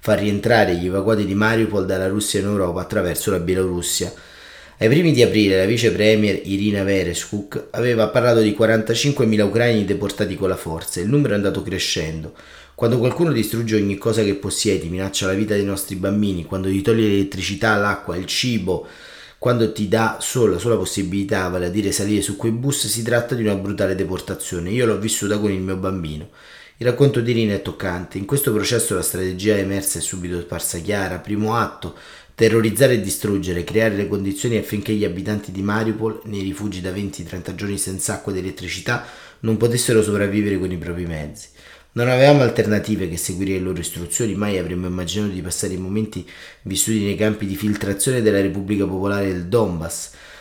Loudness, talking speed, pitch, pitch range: -20 LUFS, 185 wpm, 100 Hz, 95-110 Hz